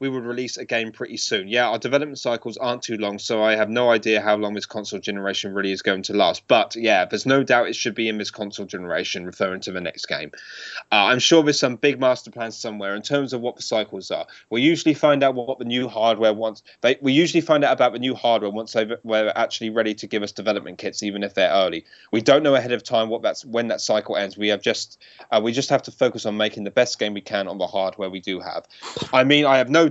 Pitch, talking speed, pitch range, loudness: 115 Hz, 265 wpm, 105-130 Hz, -21 LUFS